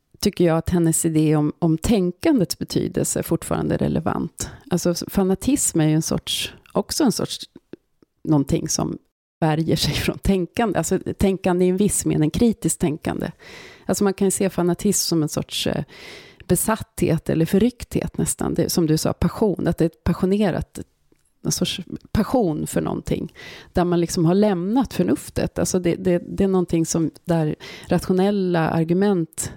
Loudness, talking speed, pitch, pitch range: -21 LUFS, 160 wpm, 175 Hz, 160-195 Hz